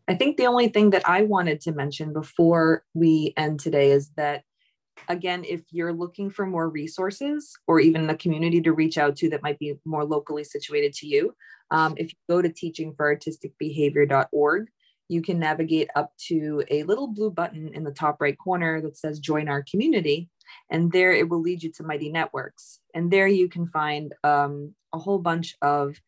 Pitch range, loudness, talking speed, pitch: 150-175 Hz, -24 LUFS, 190 wpm, 160 Hz